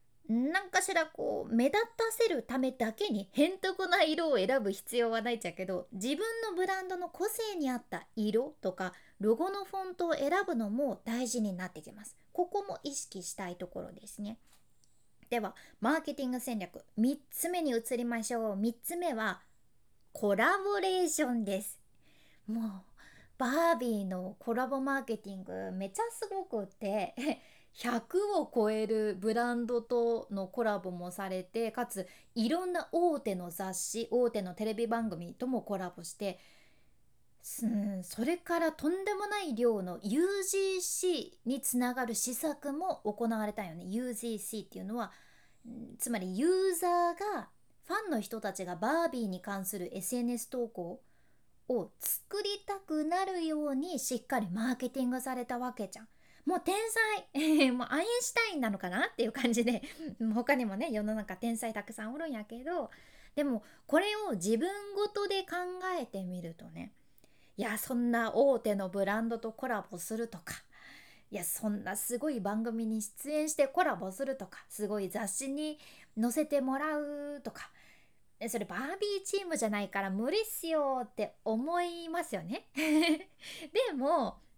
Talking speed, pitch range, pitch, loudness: 305 characters per minute, 215-325 Hz, 245 Hz, -34 LUFS